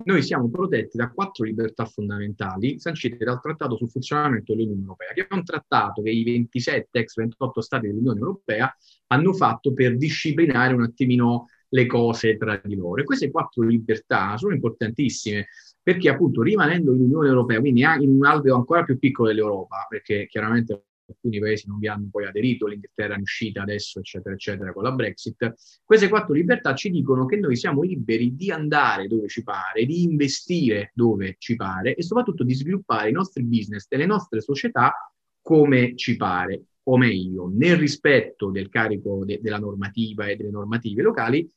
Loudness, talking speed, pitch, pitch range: -22 LUFS, 175 wpm, 120 Hz, 110-145 Hz